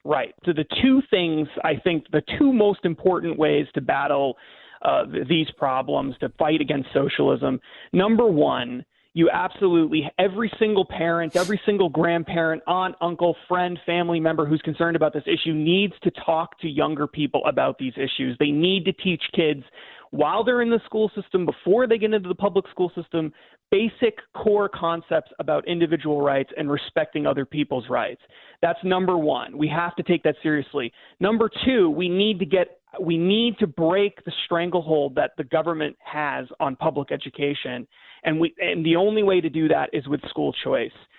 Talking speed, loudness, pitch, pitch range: 175 wpm, -23 LUFS, 170 Hz, 155-190 Hz